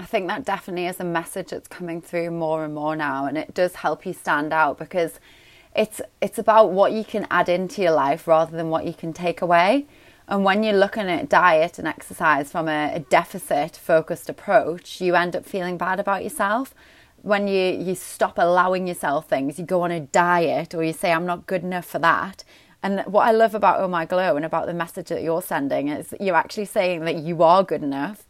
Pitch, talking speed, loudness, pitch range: 175 Hz, 225 wpm, -22 LUFS, 165-195 Hz